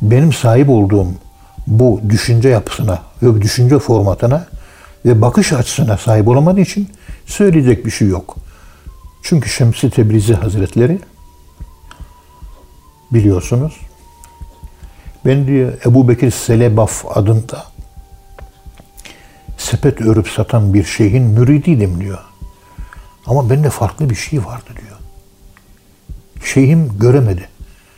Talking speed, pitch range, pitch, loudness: 100 wpm, 80-125 Hz, 110 Hz, -12 LUFS